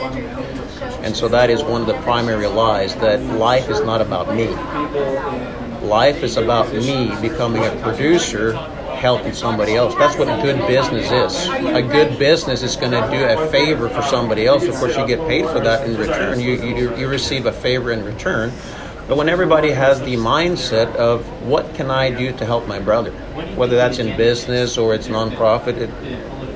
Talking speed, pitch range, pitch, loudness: 190 wpm, 115-130 Hz, 120 Hz, -17 LUFS